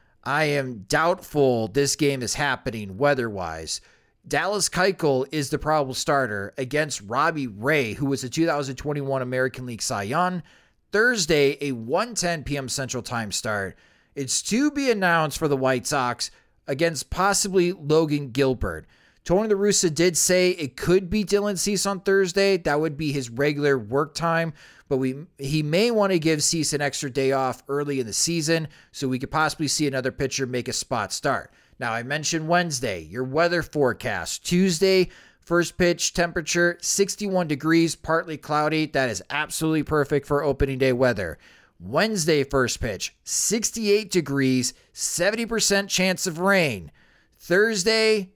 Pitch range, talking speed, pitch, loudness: 135-175 Hz, 155 wpm, 150 Hz, -23 LUFS